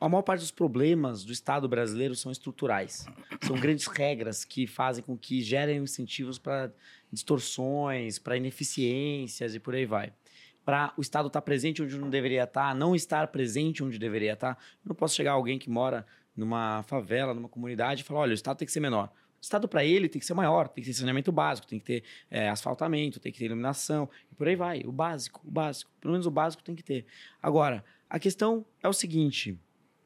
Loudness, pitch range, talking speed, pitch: -30 LUFS, 125-155 Hz, 215 wpm, 135 Hz